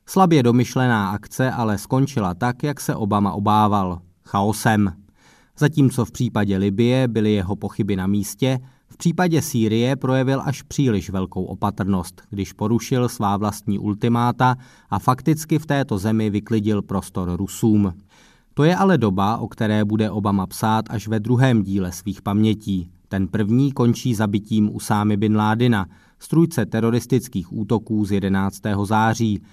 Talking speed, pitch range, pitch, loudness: 140 wpm, 100-125 Hz, 110 Hz, -20 LUFS